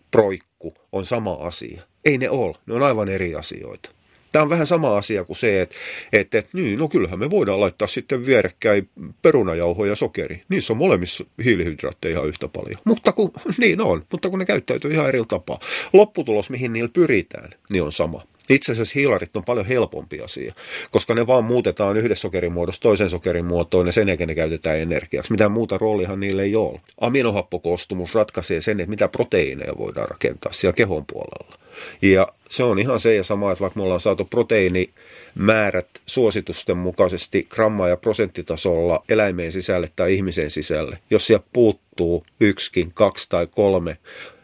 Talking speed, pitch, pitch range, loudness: 170 wpm, 100 Hz, 90-120 Hz, -20 LUFS